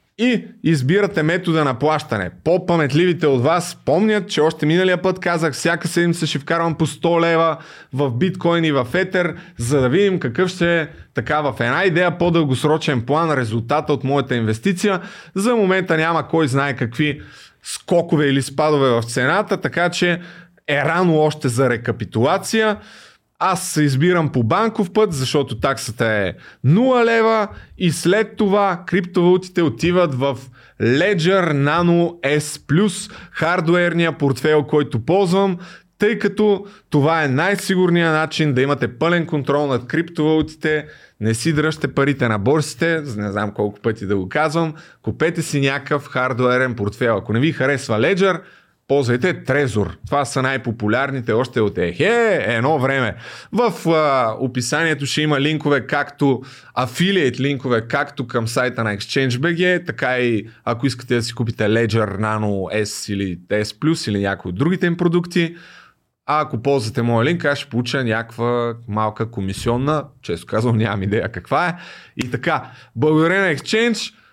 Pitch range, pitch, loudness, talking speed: 125-175 Hz, 150 Hz, -18 LUFS, 150 wpm